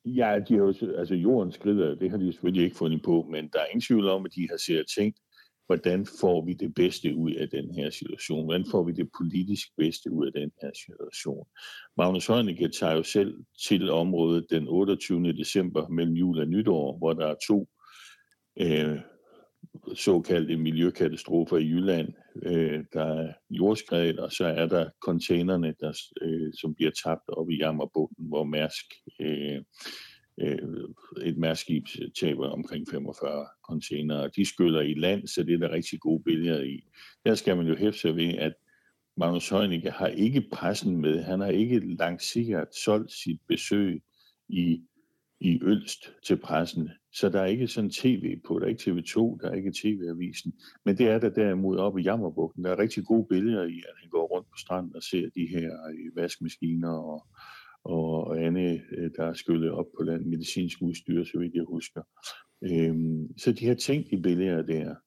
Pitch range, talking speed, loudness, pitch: 80-95 Hz, 185 wpm, -28 LUFS, 85 Hz